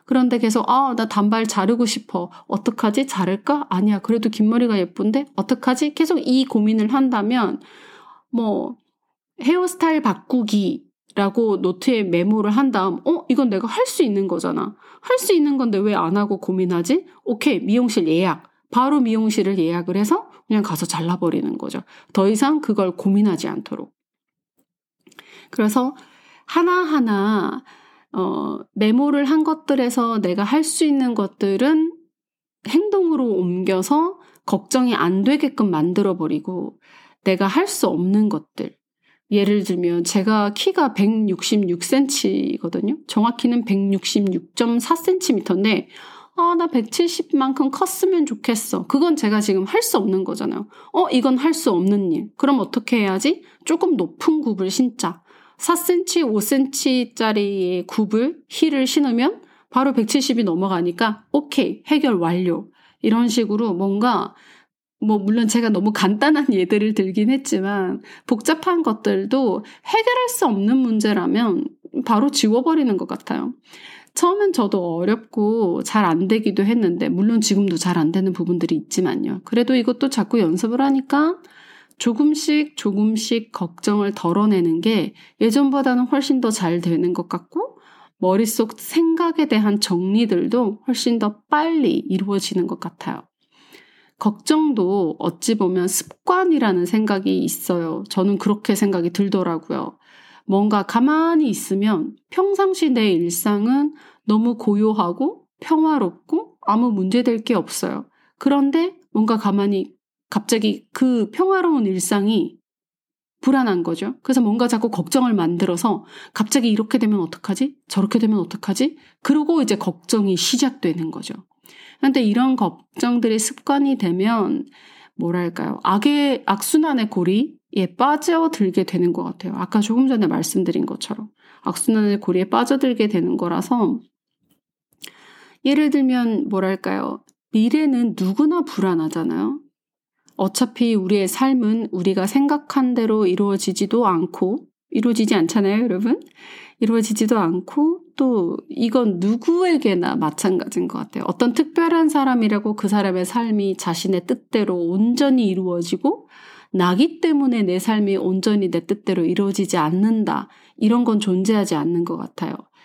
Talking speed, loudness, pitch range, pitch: 290 characters per minute, -19 LUFS, 195-285 Hz, 230 Hz